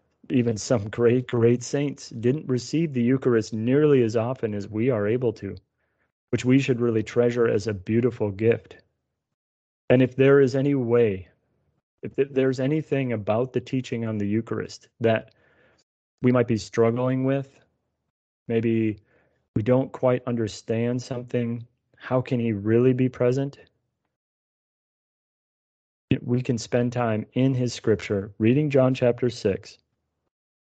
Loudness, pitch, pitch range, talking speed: -24 LUFS, 120 Hz, 110-130 Hz, 135 wpm